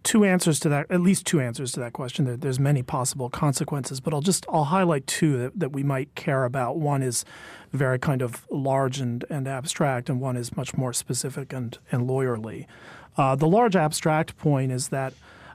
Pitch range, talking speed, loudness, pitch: 130-160 Hz, 195 wpm, -25 LUFS, 140 Hz